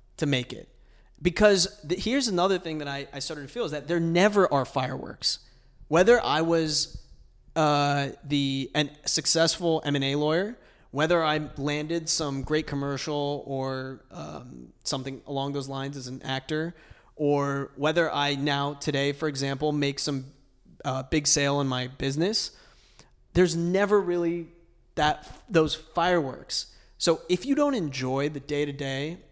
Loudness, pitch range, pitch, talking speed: -26 LUFS, 135-165 Hz, 145 Hz, 145 wpm